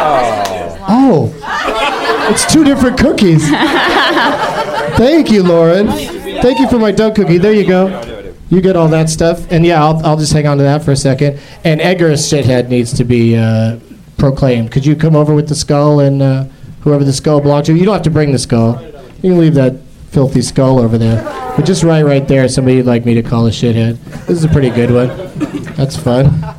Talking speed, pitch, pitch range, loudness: 210 wpm, 150 Hz, 130-170 Hz, -11 LUFS